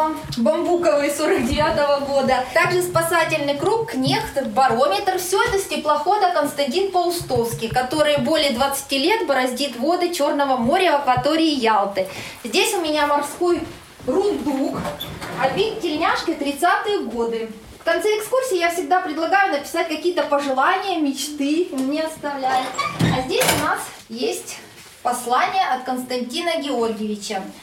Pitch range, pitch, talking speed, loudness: 270-355 Hz, 300 Hz, 120 wpm, -20 LUFS